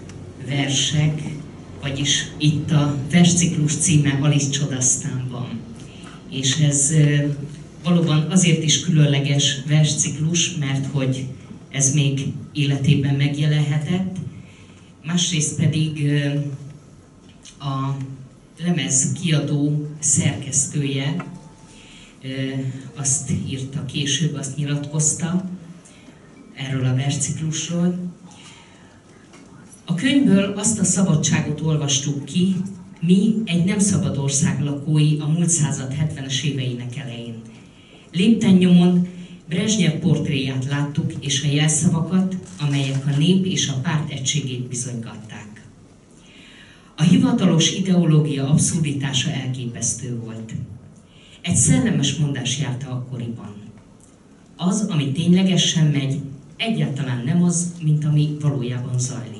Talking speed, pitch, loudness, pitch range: 95 wpm, 150 Hz, -20 LUFS, 135-165 Hz